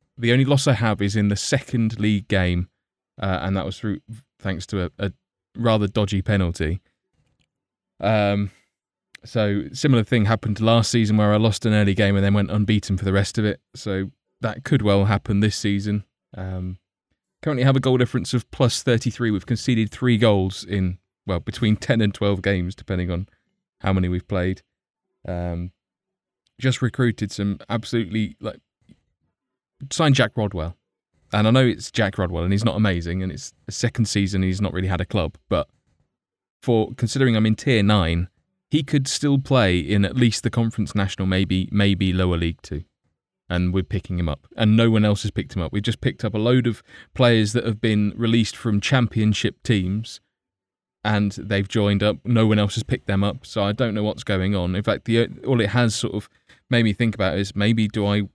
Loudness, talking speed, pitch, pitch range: -22 LUFS, 200 wpm, 105 Hz, 95-115 Hz